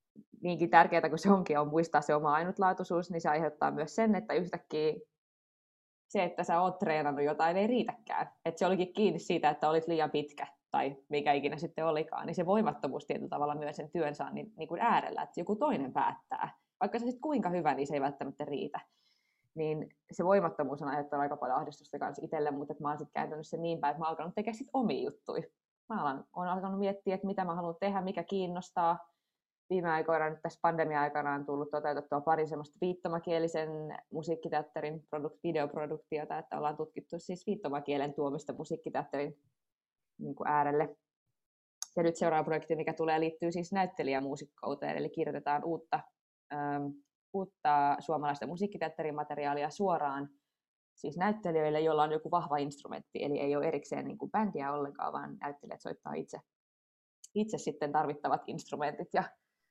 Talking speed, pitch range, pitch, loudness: 170 wpm, 145-175 Hz, 155 Hz, -34 LUFS